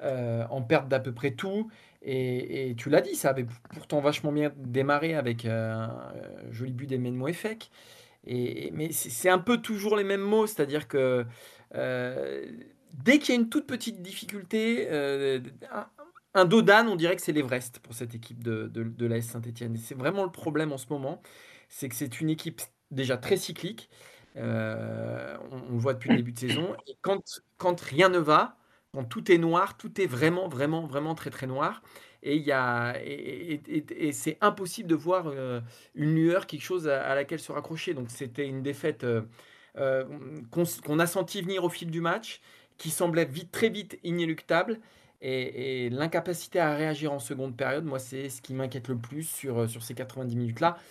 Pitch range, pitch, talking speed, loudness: 130-175 Hz, 145 Hz, 200 wpm, -29 LUFS